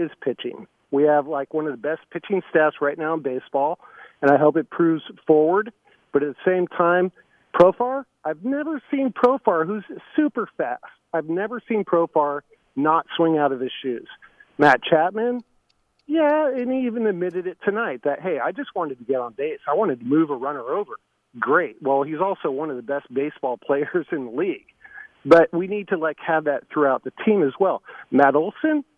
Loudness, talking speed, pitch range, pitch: -22 LUFS, 195 wpm, 150-245 Hz, 175 Hz